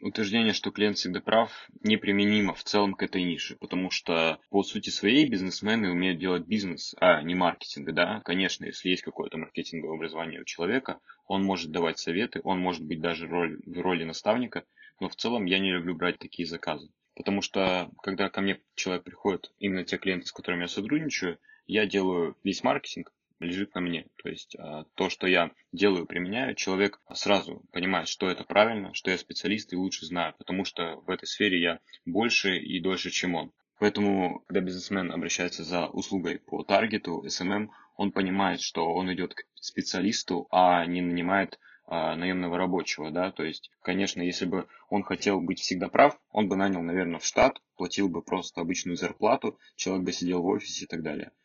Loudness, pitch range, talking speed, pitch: -28 LUFS, 90-100 Hz, 180 wpm, 90 Hz